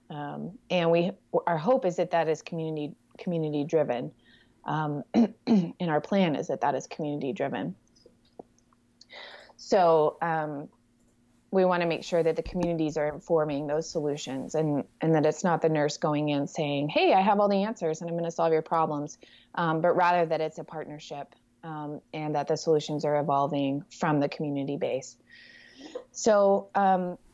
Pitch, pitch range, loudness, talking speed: 160 Hz, 150-175 Hz, -27 LUFS, 175 wpm